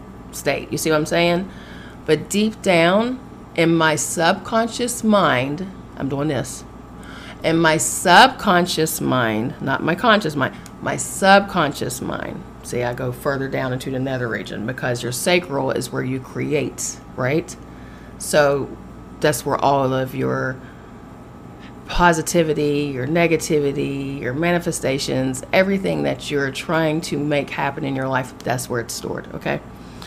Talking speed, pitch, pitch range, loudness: 140 wpm, 145 Hz, 125-165 Hz, -20 LUFS